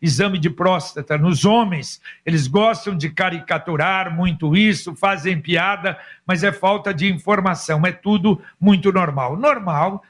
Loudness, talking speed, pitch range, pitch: -18 LUFS, 135 wpm, 165-200 Hz, 185 Hz